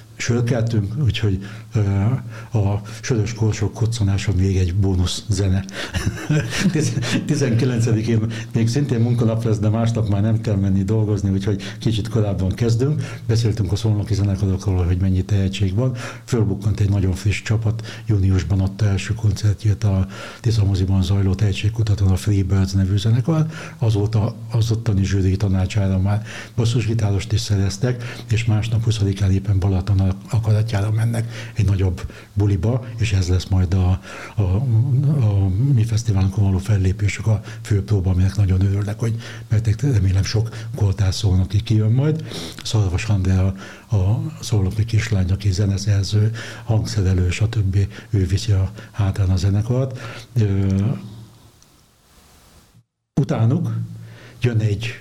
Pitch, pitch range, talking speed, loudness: 105 Hz, 100-115 Hz, 130 wpm, -20 LUFS